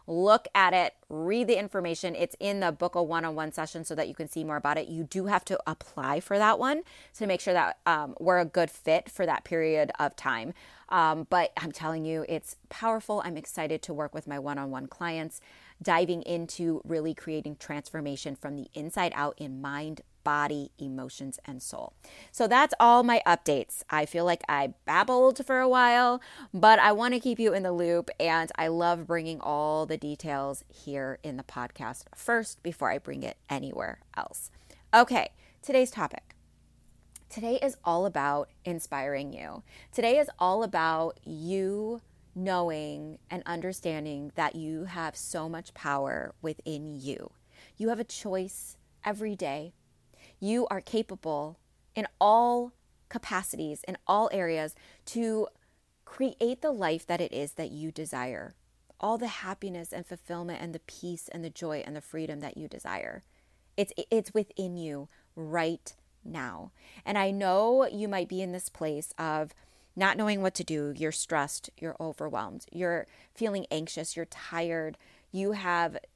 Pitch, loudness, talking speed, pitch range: 170 Hz, -29 LUFS, 170 wpm, 155-195 Hz